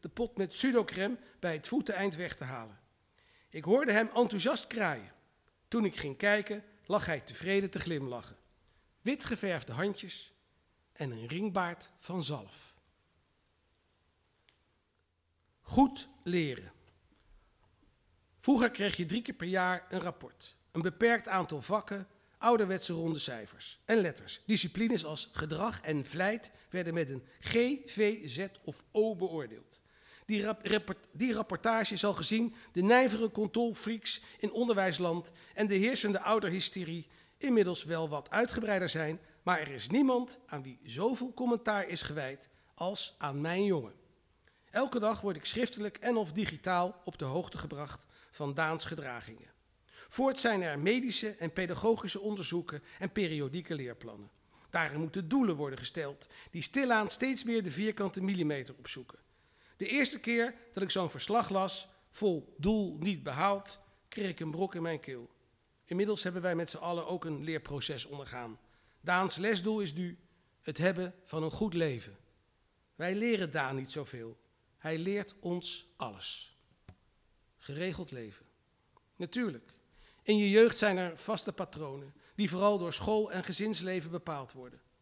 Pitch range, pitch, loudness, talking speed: 145-210 Hz, 180 Hz, -33 LUFS, 145 wpm